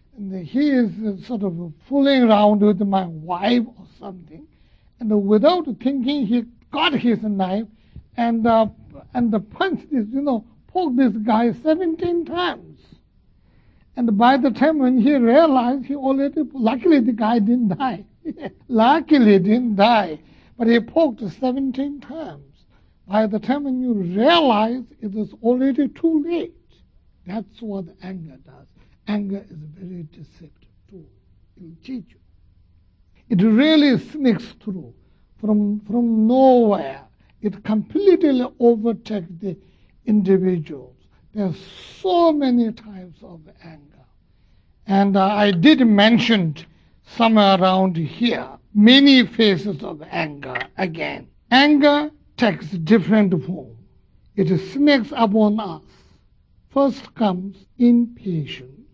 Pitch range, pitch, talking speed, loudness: 190-260 Hz, 220 Hz, 125 wpm, -18 LUFS